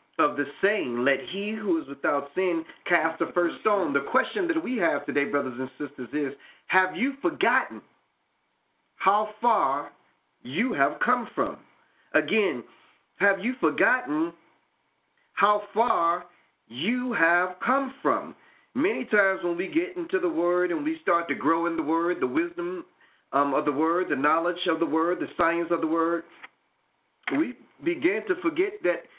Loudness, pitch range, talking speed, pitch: -26 LUFS, 165-275 Hz, 160 wpm, 185 Hz